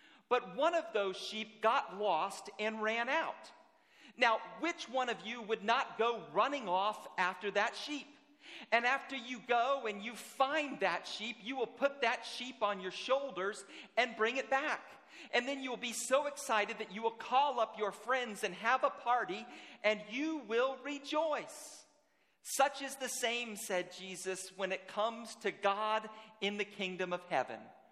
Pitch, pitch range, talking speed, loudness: 230 Hz, 210-270 Hz, 175 wpm, -36 LUFS